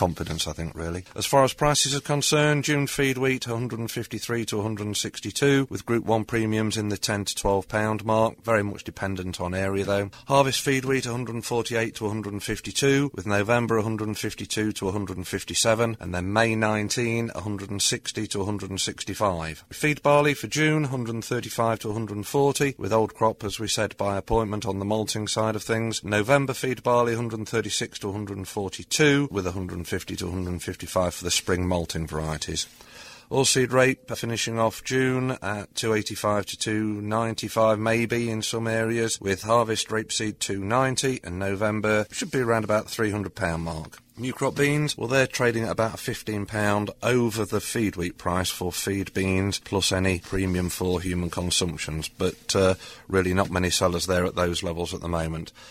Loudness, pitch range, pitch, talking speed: -25 LUFS, 95-115 Hz, 110 Hz, 165 wpm